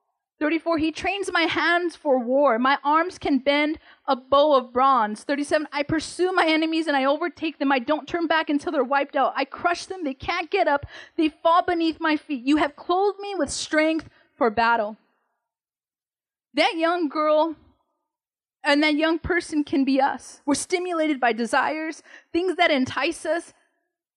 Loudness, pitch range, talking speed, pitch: -23 LUFS, 280-335 Hz, 175 wpm, 310 Hz